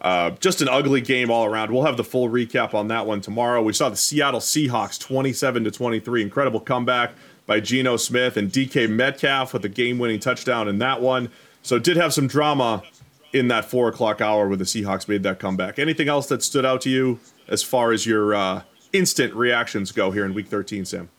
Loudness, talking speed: -21 LUFS, 215 wpm